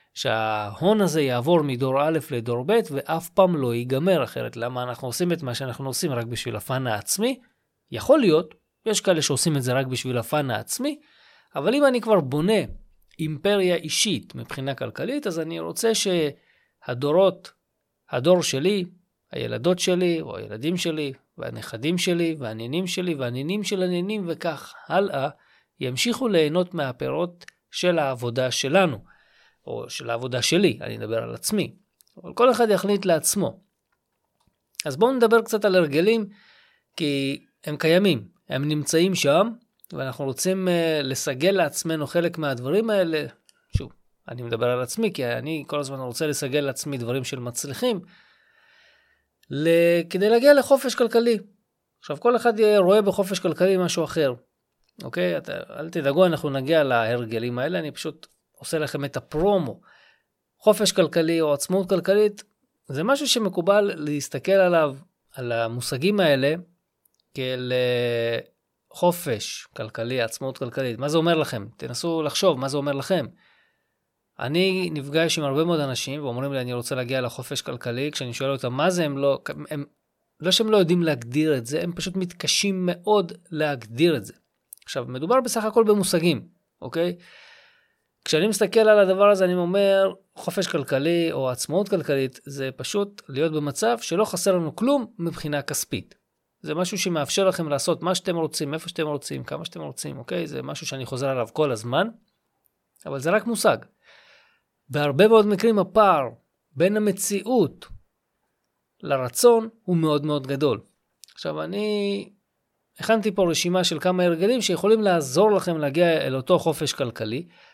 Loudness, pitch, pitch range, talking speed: -23 LUFS, 165 Hz, 135-195 Hz, 145 wpm